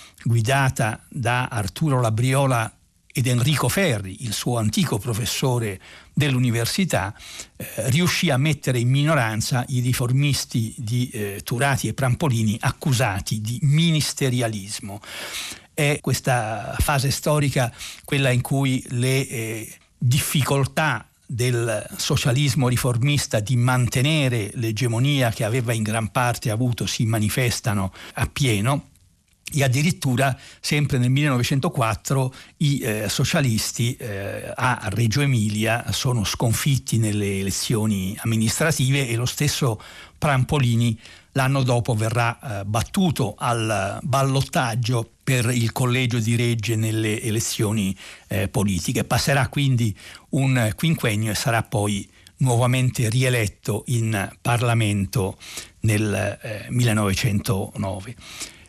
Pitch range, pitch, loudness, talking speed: 110-135 Hz, 120 Hz, -22 LUFS, 105 wpm